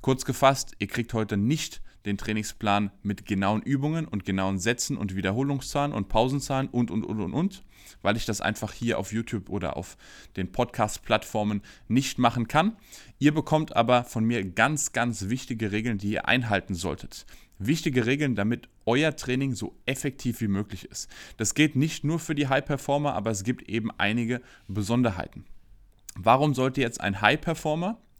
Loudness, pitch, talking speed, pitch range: -27 LUFS, 115 Hz, 165 wpm, 105-135 Hz